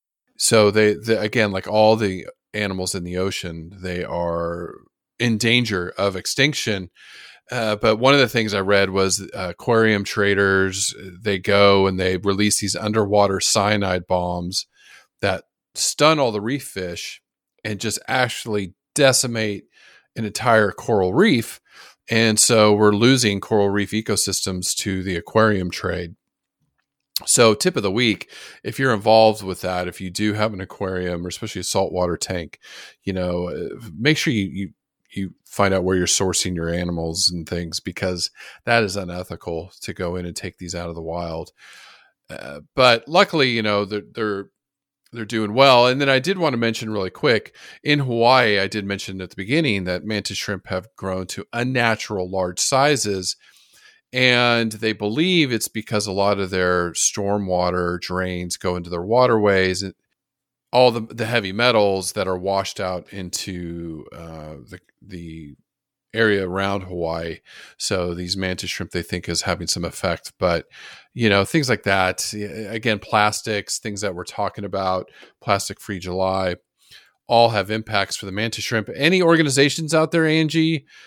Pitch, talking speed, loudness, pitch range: 100 Hz, 165 wpm, -20 LUFS, 90-110 Hz